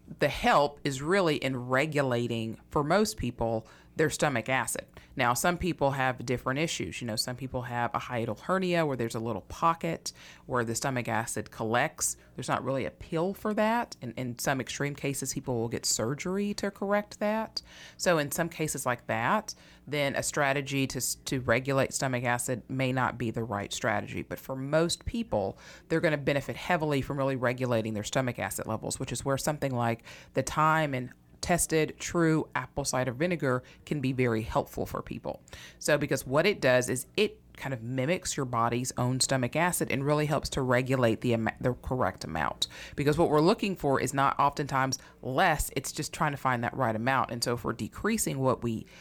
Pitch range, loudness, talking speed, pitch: 120-155 Hz, -29 LUFS, 195 wpm, 135 Hz